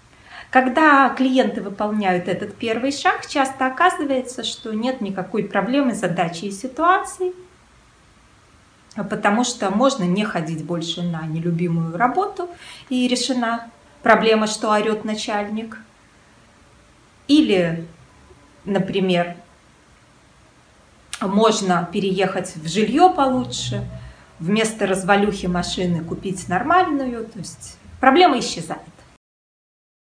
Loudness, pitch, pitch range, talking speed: -20 LUFS, 215 Hz, 180-255 Hz, 90 wpm